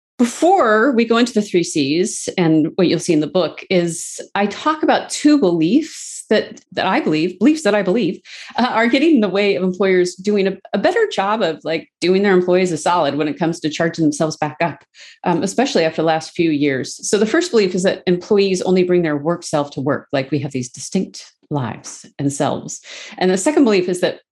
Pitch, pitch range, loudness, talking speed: 180 Hz, 160-210 Hz, -17 LUFS, 225 wpm